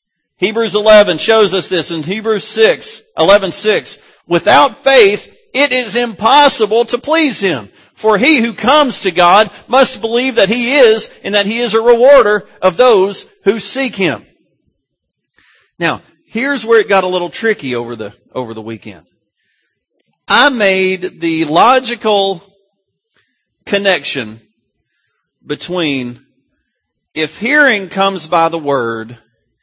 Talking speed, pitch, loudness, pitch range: 130 wpm, 200 Hz, -11 LUFS, 165-240 Hz